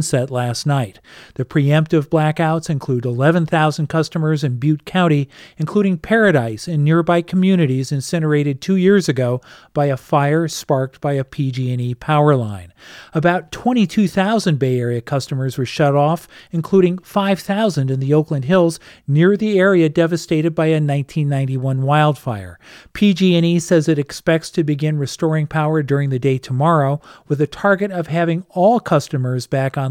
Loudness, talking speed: -17 LUFS, 150 wpm